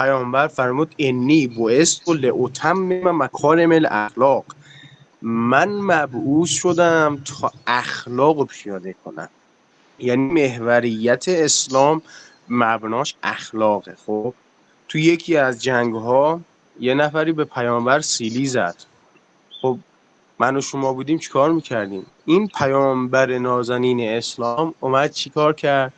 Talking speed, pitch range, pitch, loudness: 115 wpm, 120-155 Hz, 135 Hz, -19 LUFS